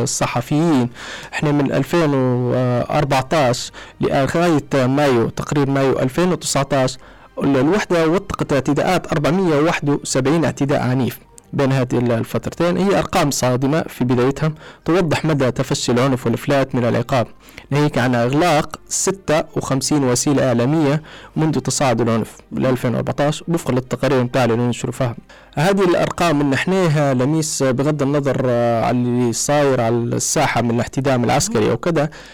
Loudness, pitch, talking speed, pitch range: -18 LUFS, 140 Hz, 115 wpm, 125-155 Hz